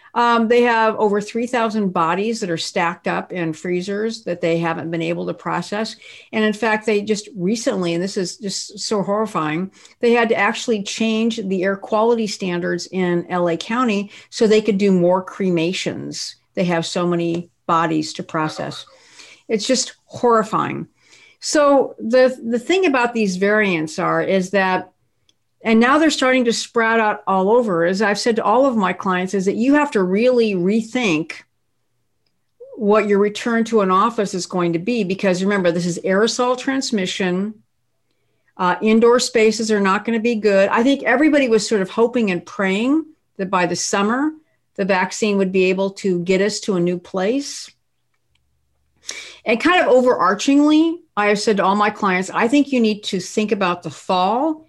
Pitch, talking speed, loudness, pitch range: 205 Hz, 180 wpm, -18 LUFS, 185-230 Hz